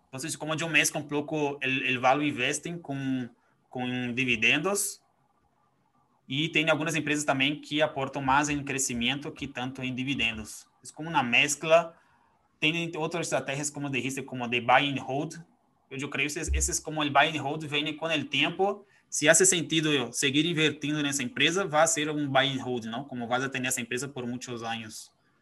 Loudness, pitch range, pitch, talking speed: -27 LUFS, 130-155 Hz, 140 Hz, 180 wpm